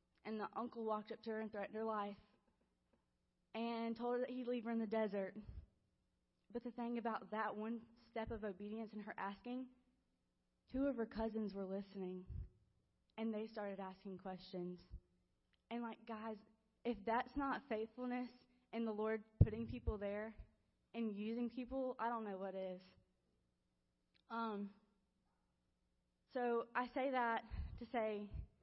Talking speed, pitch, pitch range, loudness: 150 wpm, 220 Hz, 200-235 Hz, -45 LUFS